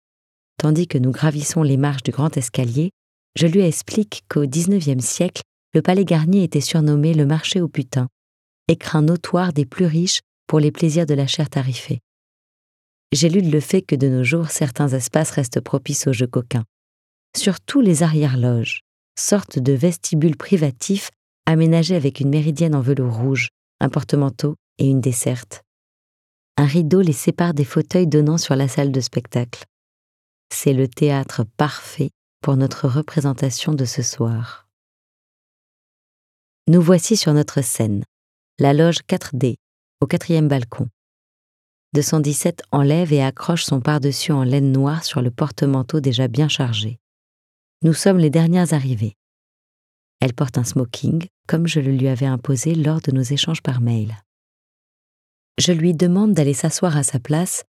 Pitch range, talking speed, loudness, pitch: 130-165 Hz, 155 wpm, -19 LUFS, 145 Hz